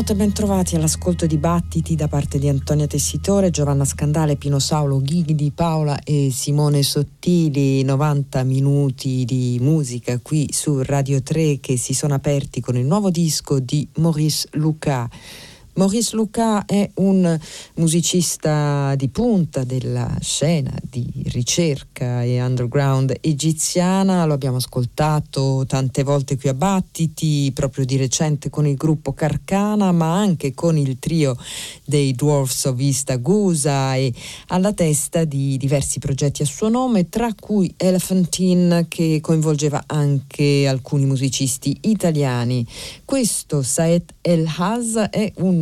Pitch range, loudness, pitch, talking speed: 135-170 Hz, -19 LUFS, 150 Hz, 125 wpm